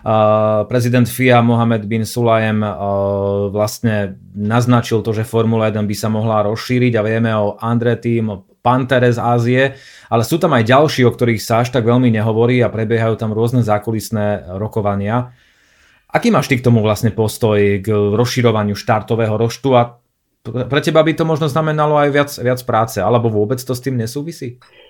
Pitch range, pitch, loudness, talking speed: 110-125 Hz, 115 Hz, -15 LUFS, 175 wpm